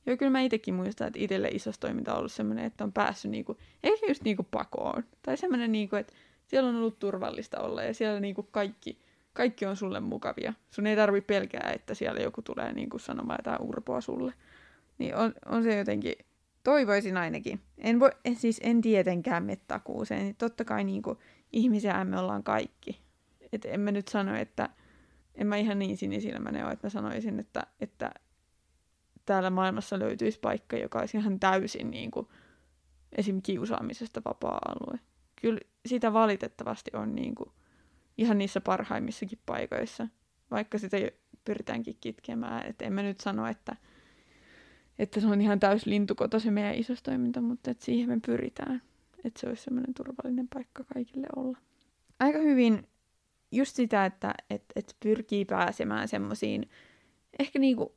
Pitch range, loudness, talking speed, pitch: 200-245 Hz, -31 LUFS, 165 wpm, 215 Hz